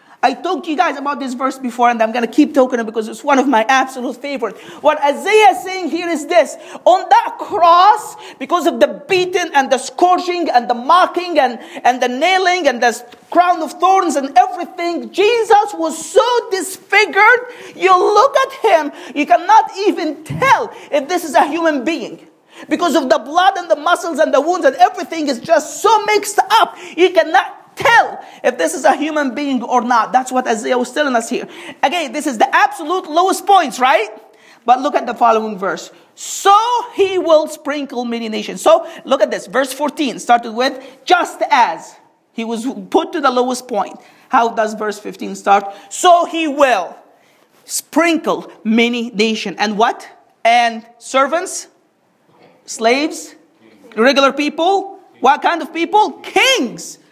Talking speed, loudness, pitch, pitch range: 175 wpm, -14 LUFS, 315 Hz, 255-360 Hz